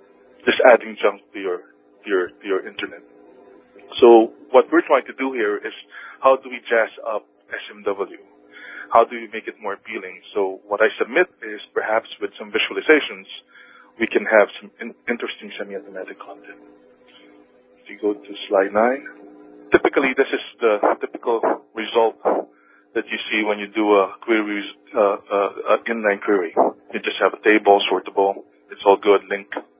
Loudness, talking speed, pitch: -20 LUFS, 165 wpm, 100 Hz